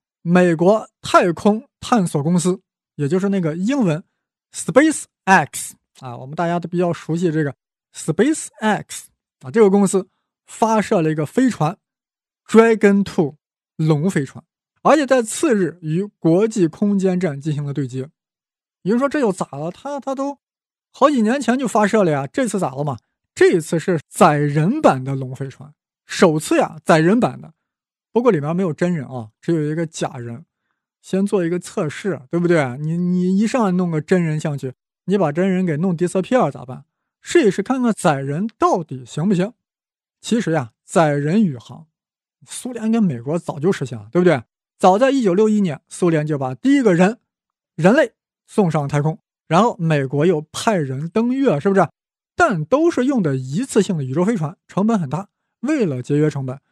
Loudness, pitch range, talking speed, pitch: -18 LUFS, 155-215 Hz, 270 characters per minute, 180 Hz